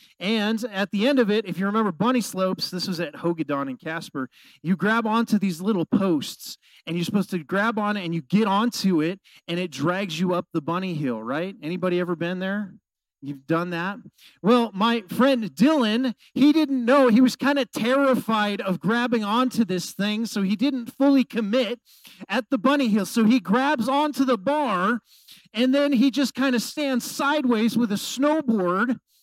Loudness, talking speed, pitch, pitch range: -23 LUFS, 190 wpm, 220 Hz, 185-255 Hz